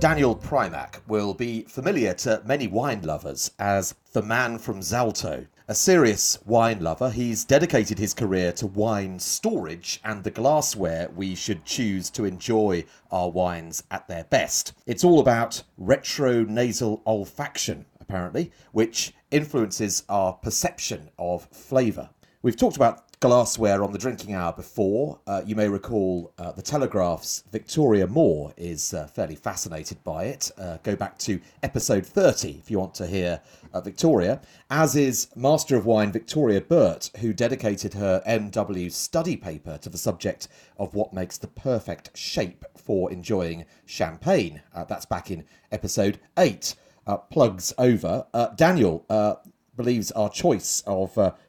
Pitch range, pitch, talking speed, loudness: 95-120 Hz, 105 Hz, 150 wpm, -24 LUFS